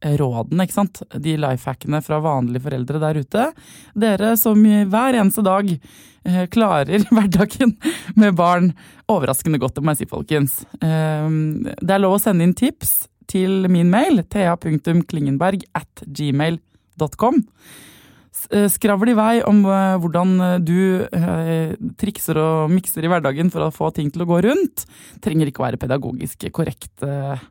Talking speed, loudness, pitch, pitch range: 150 wpm, -18 LUFS, 175 Hz, 155-205 Hz